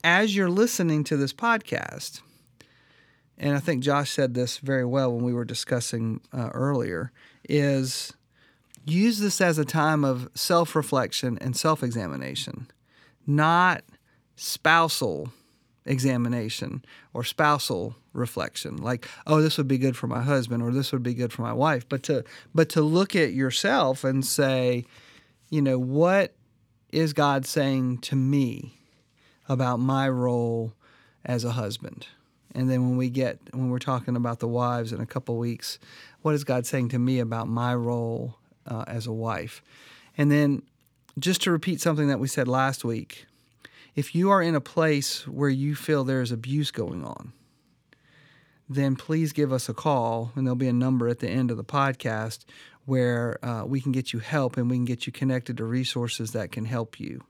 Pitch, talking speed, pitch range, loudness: 130 Hz, 175 wpm, 120-150 Hz, -26 LUFS